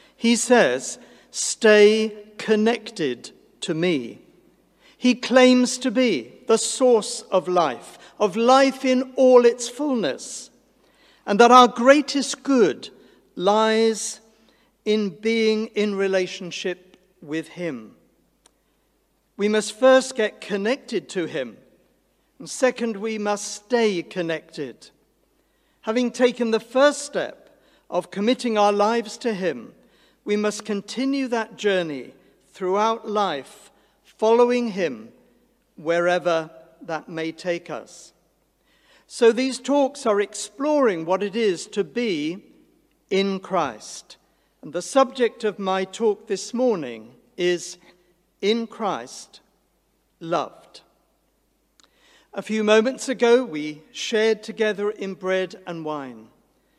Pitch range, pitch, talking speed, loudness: 190-245 Hz, 215 Hz, 110 wpm, -21 LUFS